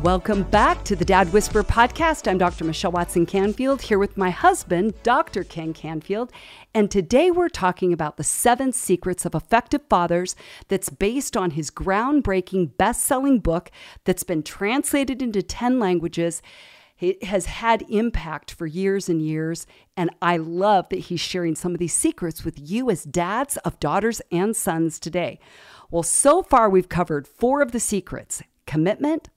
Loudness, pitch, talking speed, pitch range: -22 LUFS, 190 Hz, 165 wpm, 170-230 Hz